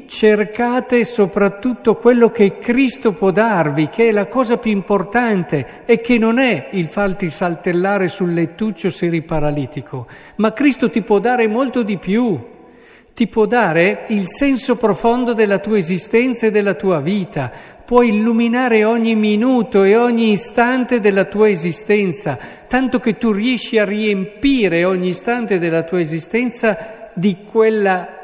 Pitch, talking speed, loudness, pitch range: 215 Hz, 145 wpm, -16 LUFS, 185-235 Hz